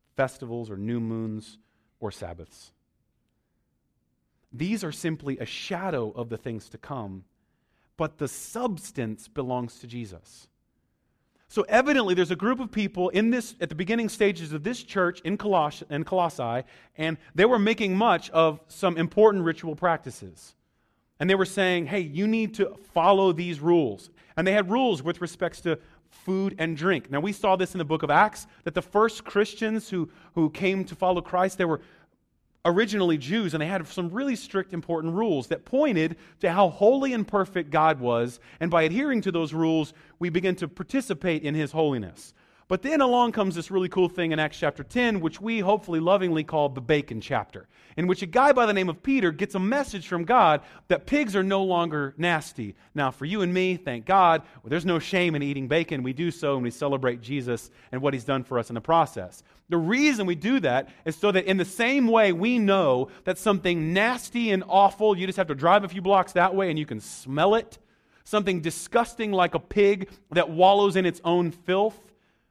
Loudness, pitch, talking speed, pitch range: -25 LUFS, 175 Hz, 200 wpm, 150-195 Hz